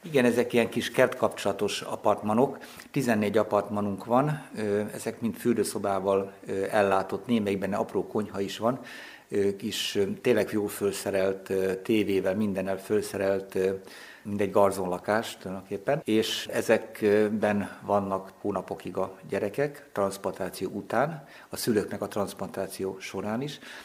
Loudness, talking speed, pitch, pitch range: -28 LUFS, 110 wpm, 100 Hz, 95-110 Hz